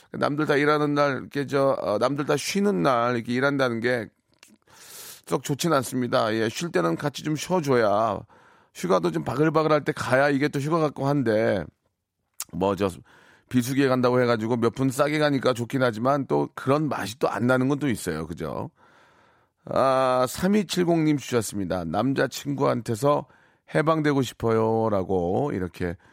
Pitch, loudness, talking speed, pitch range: 135 Hz, -24 LUFS, 305 characters per minute, 115-150 Hz